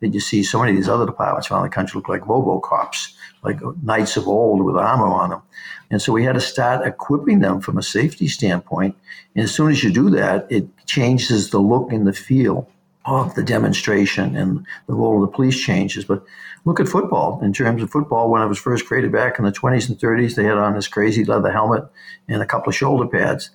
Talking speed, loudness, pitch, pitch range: 235 wpm, -18 LUFS, 115 Hz, 100-125 Hz